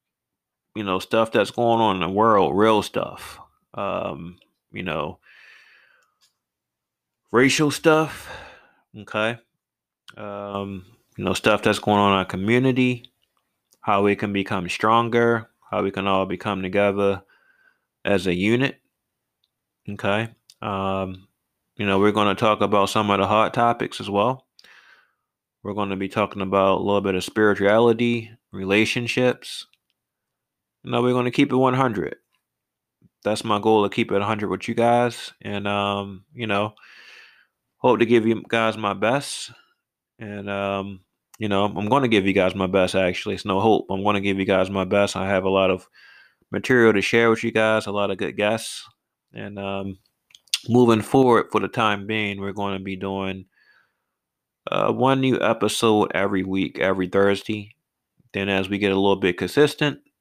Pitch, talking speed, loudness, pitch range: 105 Hz, 165 wpm, -21 LUFS, 100-115 Hz